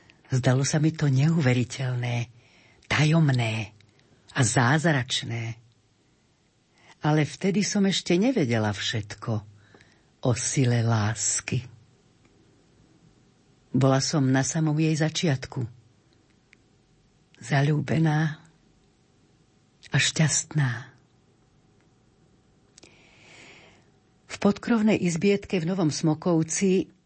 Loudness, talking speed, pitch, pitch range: -25 LUFS, 70 wpm, 135 Hz, 120-160 Hz